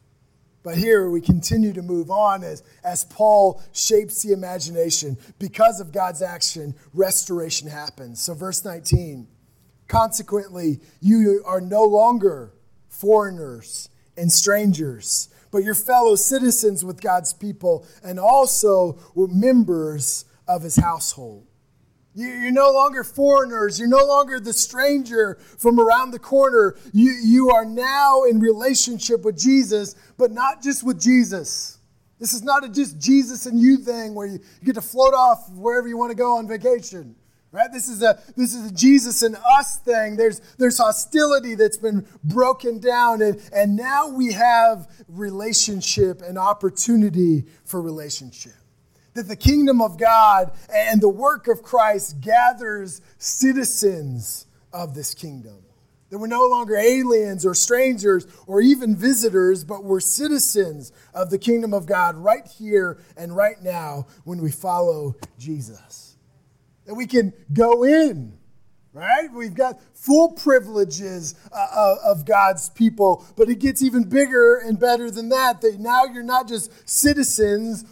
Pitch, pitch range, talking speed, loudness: 210 Hz, 175-245 Hz, 145 wpm, -19 LUFS